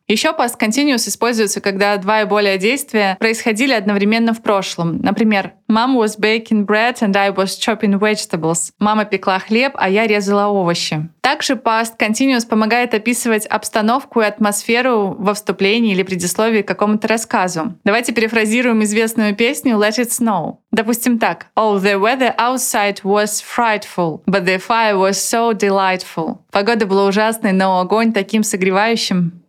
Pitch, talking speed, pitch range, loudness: 215 Hz, 150 wpm, 200-230 Hz, -15 LUFS